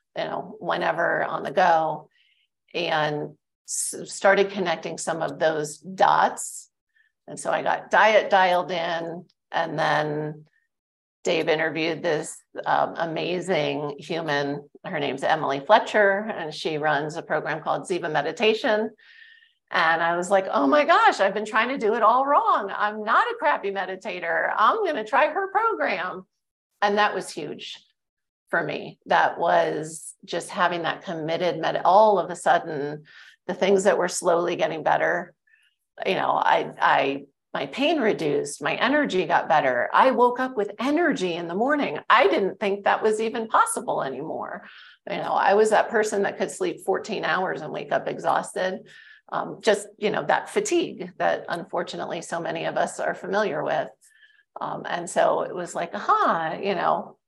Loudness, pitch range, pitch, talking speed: -23 LUFS, 165-230 Hz, 195 Hz, 165 wpm